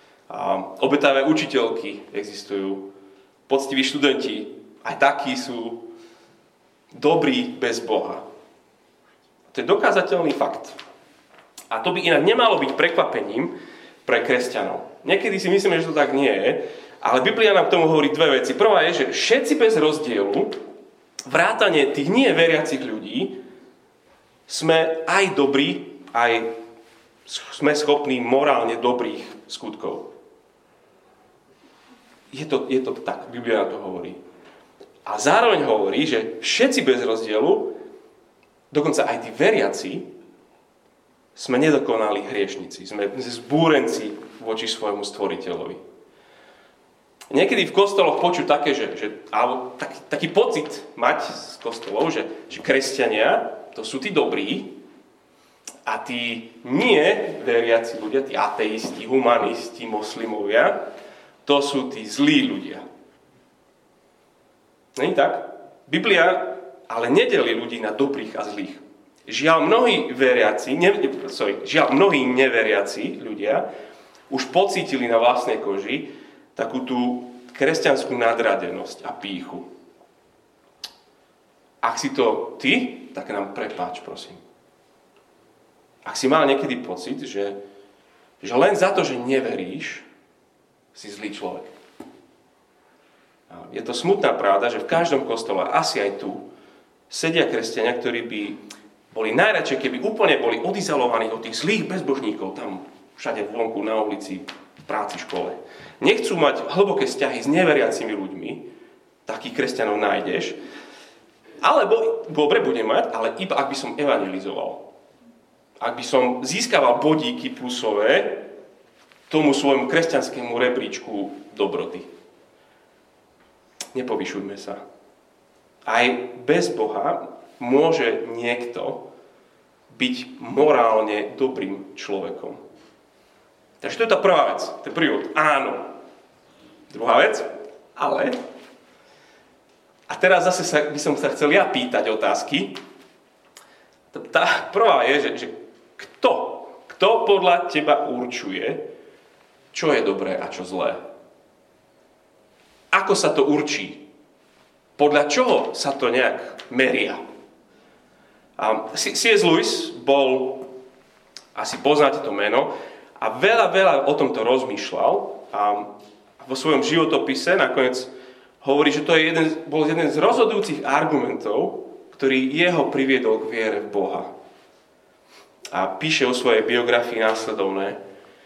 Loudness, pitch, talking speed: -21 LUFS, 145 Hz, 115 wpm